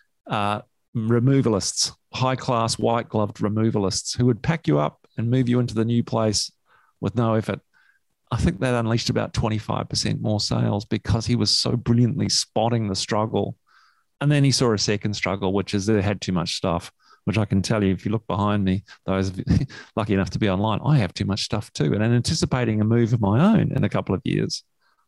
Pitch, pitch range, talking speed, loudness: 110 Hz, 100-120 Hz, 210 wpm, -23 LUFS